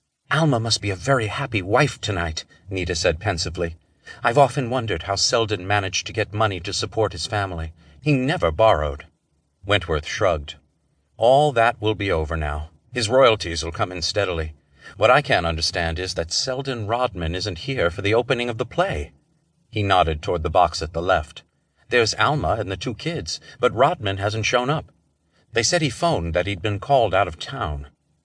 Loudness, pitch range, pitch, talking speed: -22 LUFS, 85-120 Hz, 100 Hz, 185 wpm